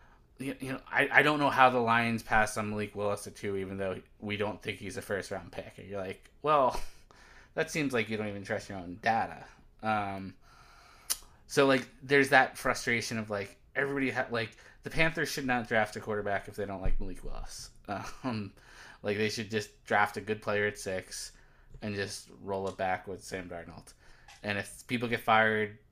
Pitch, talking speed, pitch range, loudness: 105 Hz, 200 wpm, 100-115 Hz, -31 LUFS